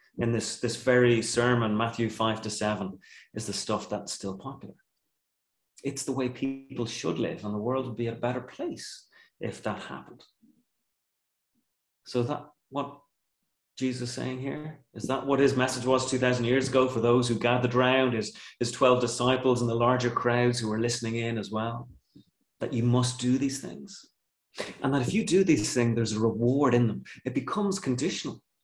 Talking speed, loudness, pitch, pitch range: 185 wpm, -28 LUFS, 120 Hz, 115-130 Hz